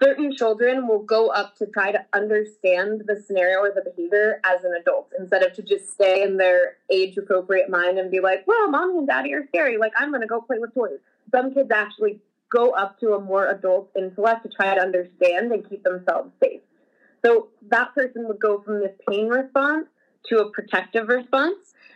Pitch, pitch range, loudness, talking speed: 215 Hz, 190-245 Hz, -21 LUFS, 205 wpm